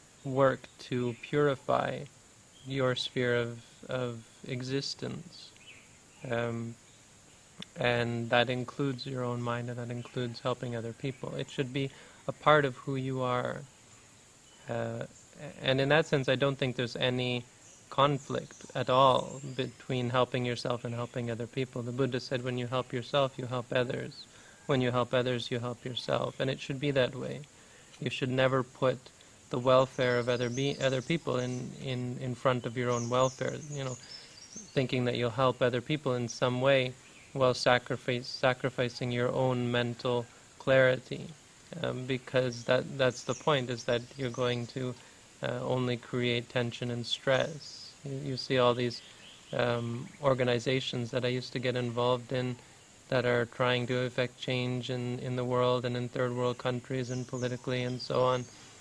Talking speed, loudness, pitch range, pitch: 165 wpm, -31 LUFS, 120-130 Hz, 125 Hz